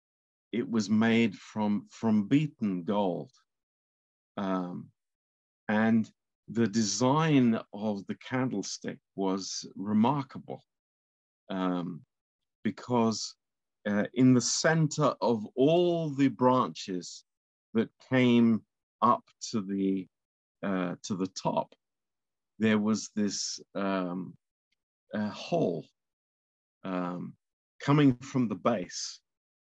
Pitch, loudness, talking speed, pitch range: 105 Hz, -29 LUFS, 95 wpm, 95-125 Hz